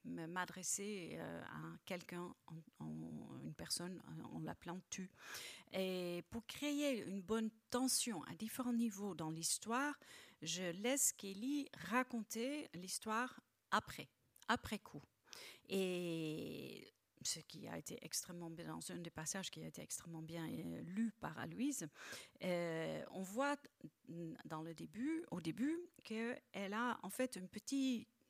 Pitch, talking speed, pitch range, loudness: 195 Hz, 135 wpm, 170-245 Hz, -44 LUFS